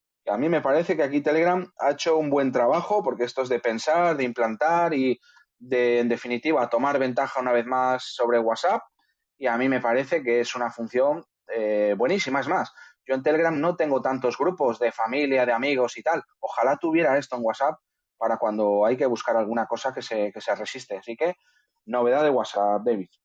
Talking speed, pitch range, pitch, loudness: 205 wpm, 115-145 Hz, 125 Hz, -24 LUFS